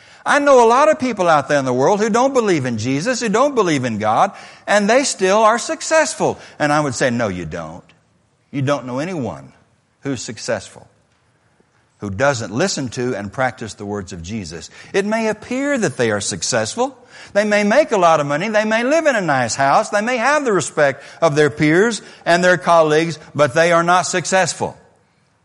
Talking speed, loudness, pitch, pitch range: 205 wpm, -16 LUFS, 170 Hz, 135-225 Hz